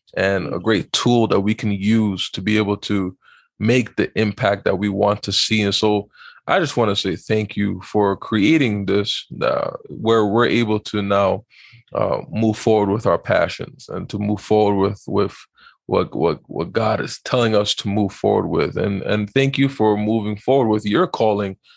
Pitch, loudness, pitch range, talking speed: 105 Hz, -19 LUFS, 100-110 Hz, 195 wpm